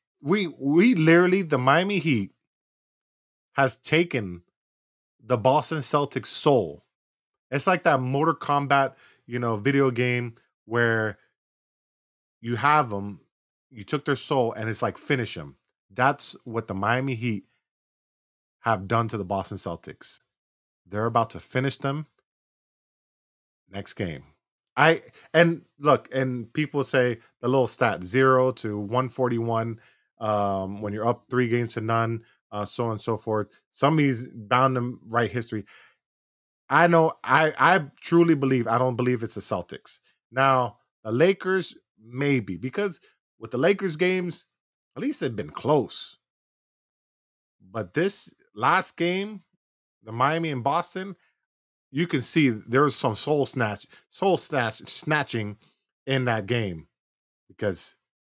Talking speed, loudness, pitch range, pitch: 135 wpm, -24 LUFS, 110-150 Hz, 125 Hz